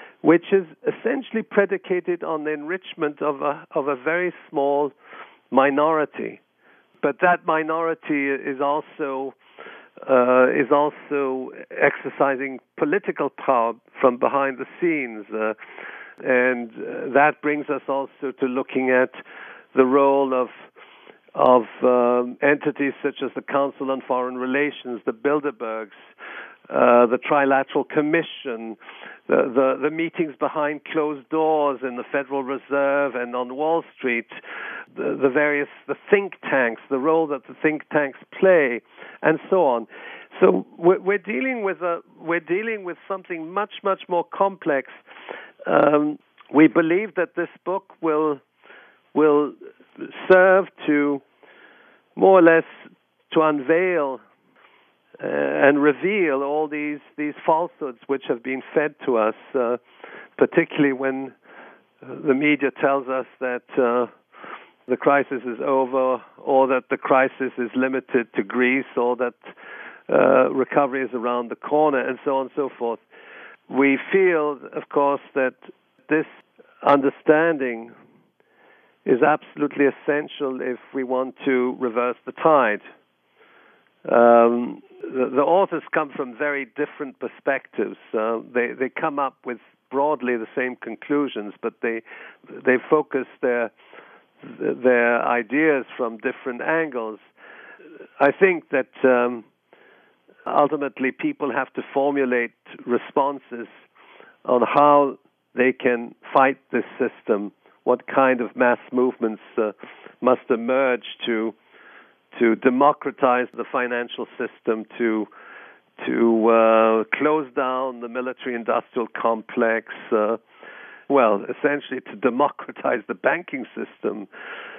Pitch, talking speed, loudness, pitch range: 140 Hz, 125 wpm, -22 LUFS, 125-150 Hz